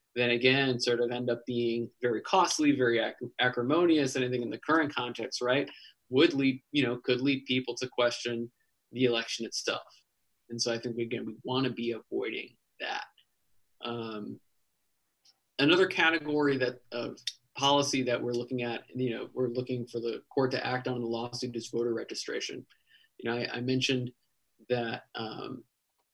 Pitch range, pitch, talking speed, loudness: 120-135 Hz, 125 Hz, 170 wpm, -30 LUFS